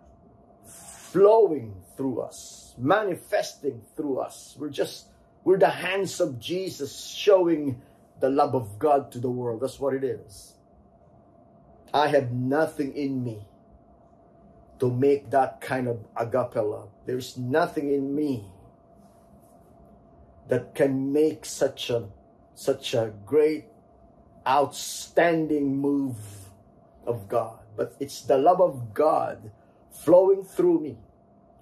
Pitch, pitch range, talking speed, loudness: 135 Hz, 120-155 Hz, 115 wpm, -25 LUFS